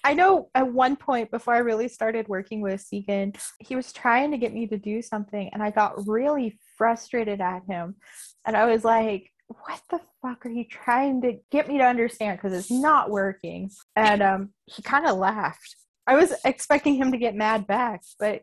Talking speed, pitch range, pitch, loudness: 200 wpm, 205-255 Hz, 225 Hz, -24 LUFS